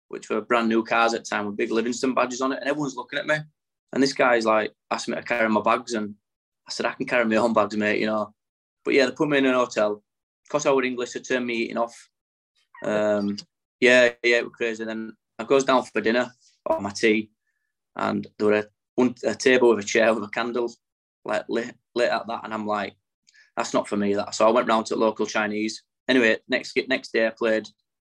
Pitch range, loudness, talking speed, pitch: 105-125 Hz, -23 LUFS, 245 wpm, 115 Hz